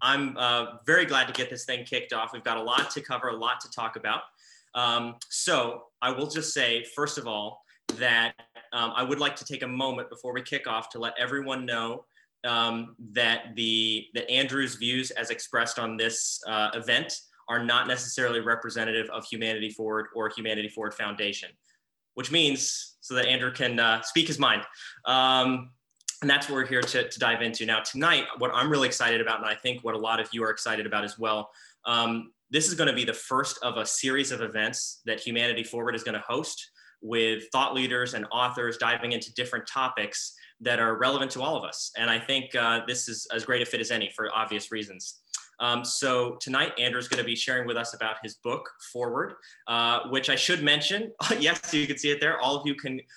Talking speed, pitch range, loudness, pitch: 215 wpm, 115-130 Hz, -27 LUFS, 120 Hz